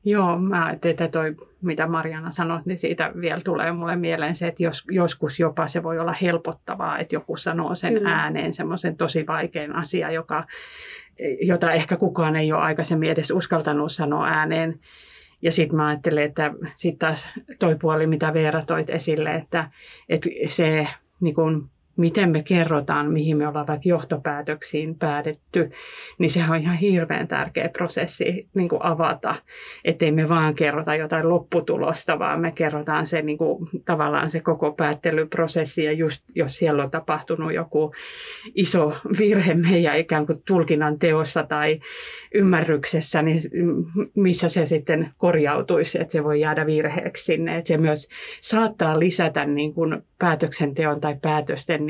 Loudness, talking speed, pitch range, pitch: -23 LUFS, 150 wpm, 155-170 Hz, 160 Hz